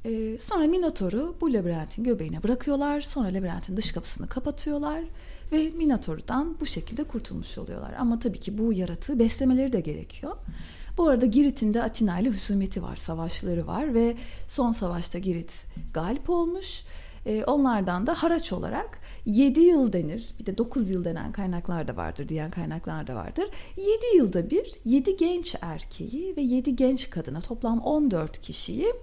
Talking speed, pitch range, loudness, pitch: 150 wpm, 190-295 Hz, -26 LUFS, 235 Hz